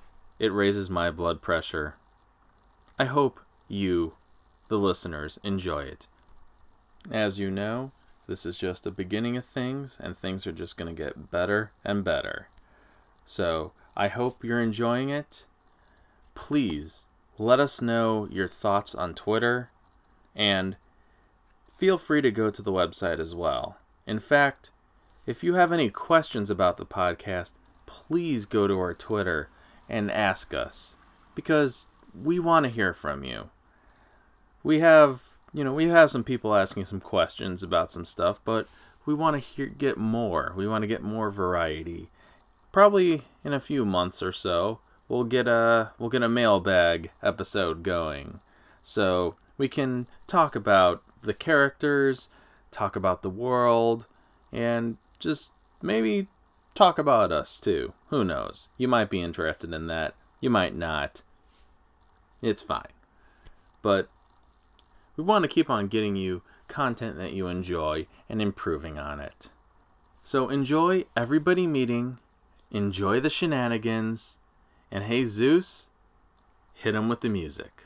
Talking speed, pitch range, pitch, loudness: 140 wpm, 90-125 Hz, 105 Hz, -26 LUFS